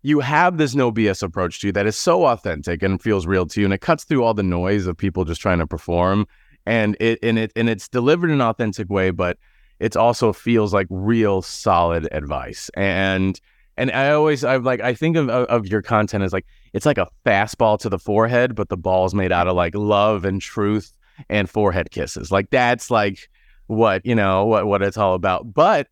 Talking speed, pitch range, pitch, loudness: 220 wpm, 95-115 Hz, 105 Hz, -19 LUFS